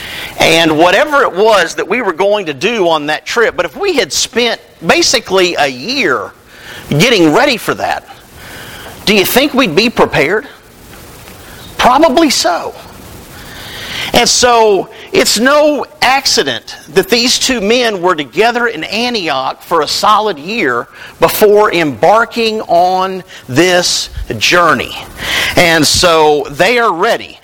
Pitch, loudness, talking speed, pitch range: 205 Hz, -10 LUFS, 130 wpm, 165-245 Hz